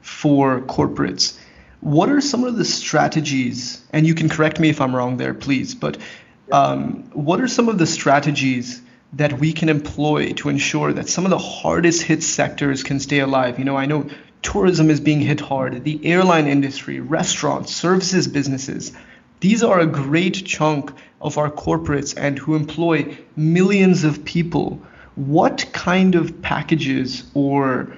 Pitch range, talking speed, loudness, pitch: 135-165 Hz, 165 wpm, -18 LUFS, 150 Hz